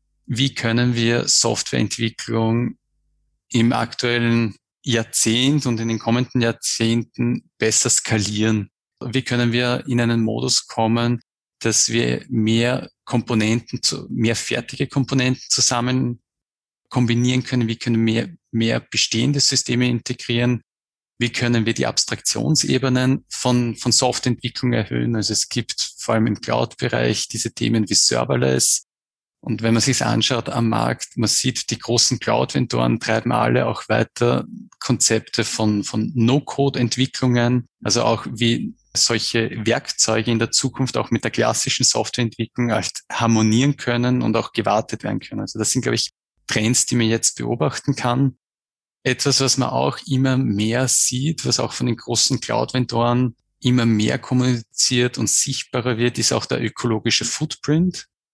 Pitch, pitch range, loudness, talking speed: 120 Hz, 115-125 Hz, -19 LUFS, 140 wpm